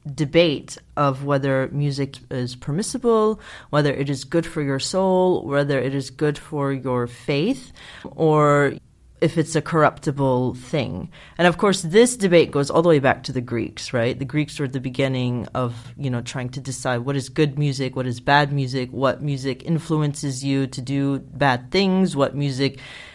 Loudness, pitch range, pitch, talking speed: -21 LUFS, 130-155 Hz, 140 Hz, 180 wpm